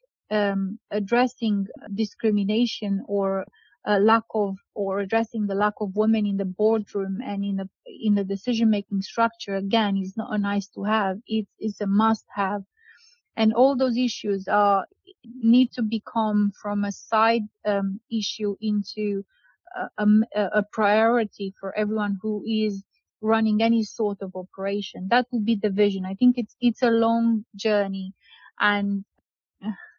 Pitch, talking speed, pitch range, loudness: 210 Hz, 150 wpm, 200-225 Hz, -24 LUFS